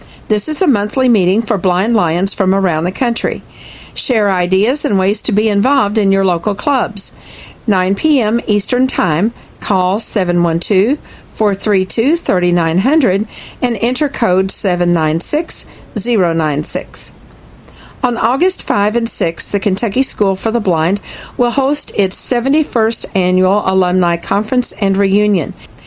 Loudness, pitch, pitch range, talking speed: -13 LUFS, 205 Hz, 185-240 Hz, 130 wpm